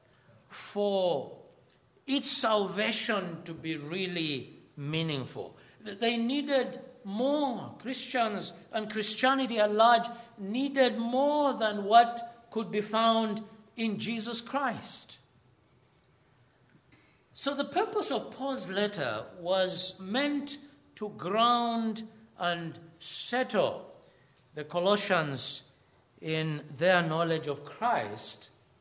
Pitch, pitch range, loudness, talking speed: 215 Hz, 175-240 Hz, -30 LUFS, 90 wpm